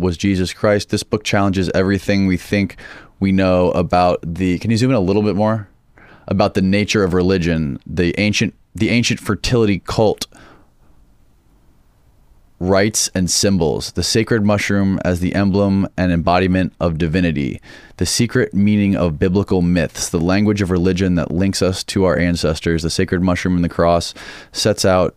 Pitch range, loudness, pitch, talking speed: 90-100 Hz, -17 LUFS, 95 Hz, 165 wpm